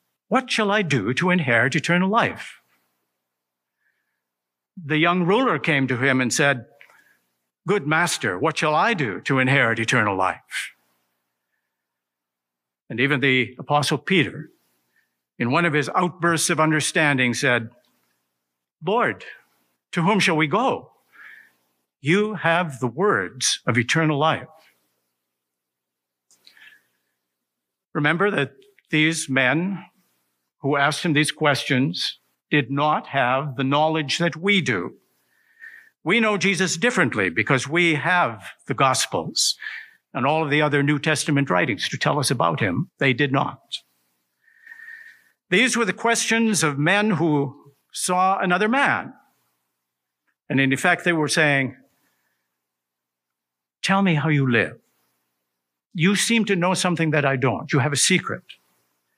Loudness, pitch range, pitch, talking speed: -21 LUFS, 115-180 Hz, 150 Hz, 130 wpm